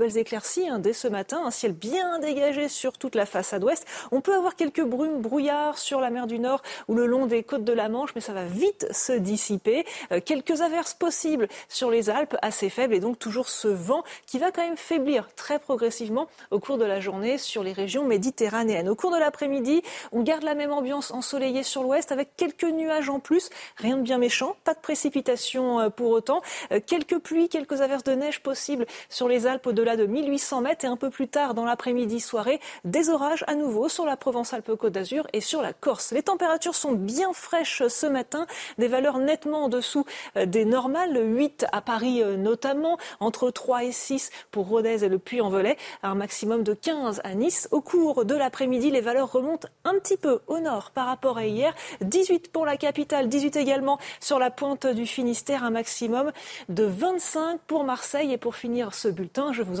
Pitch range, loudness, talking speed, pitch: 235-300 Hz, -25 LUFS, 205 wpm, 265 Hz